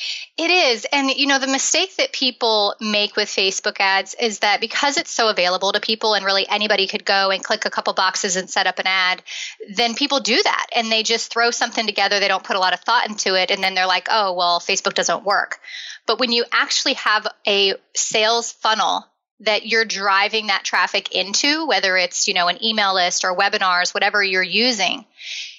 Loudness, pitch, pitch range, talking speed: -18 LUFS, 210 Hz, 195-235 Hz, 210 wpm